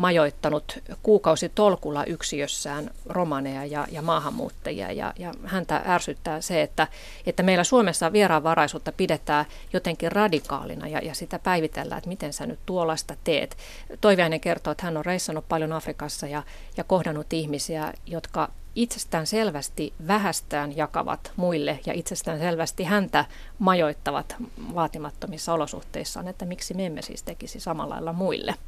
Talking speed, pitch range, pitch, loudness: 135 wpm, 155-185 Hz, 165 Hz, -26 LUFS